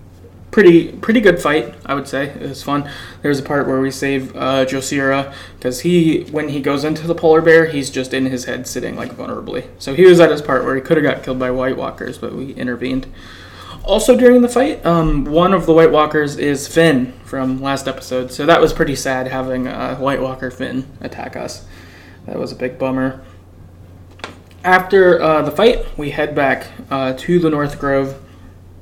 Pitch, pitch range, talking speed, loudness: 135 Hz, 130-160 Hz, 205 wpm, -15 LUFS